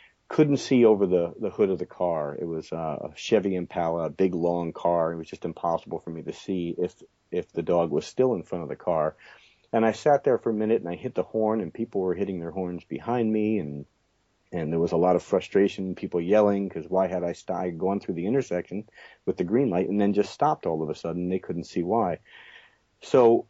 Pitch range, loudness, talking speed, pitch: 85-110 Hz, -26 LUFS, 235 wpm, 95 Hz